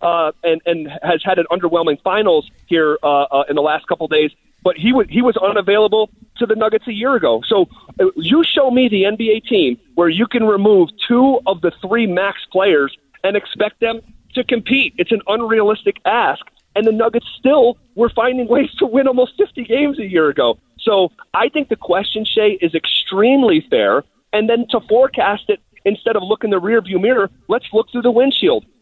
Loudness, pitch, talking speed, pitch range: -16 LUFS, 215 Hz, 200 wpm, 185-245 Hz